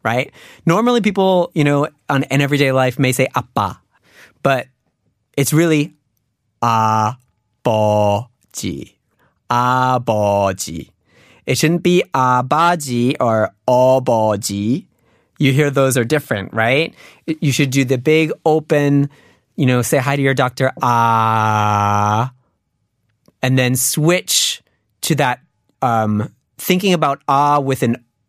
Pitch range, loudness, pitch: 115-145 Hz, -16 LUFS, 130 Hz